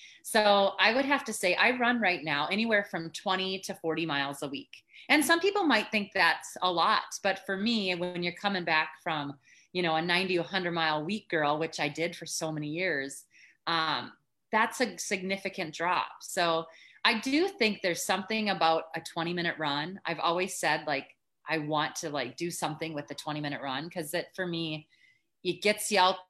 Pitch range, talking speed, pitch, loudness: 160-205 Hz, 205 wpm, 180 Hz, -29 LUFS